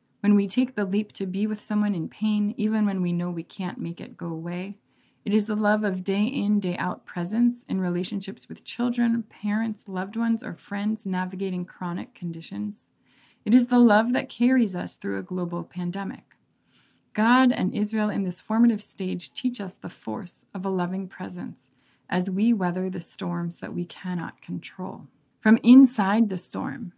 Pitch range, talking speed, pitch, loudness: 180-220 Hz, 180 wpm, 205 Hz, -25 LUFS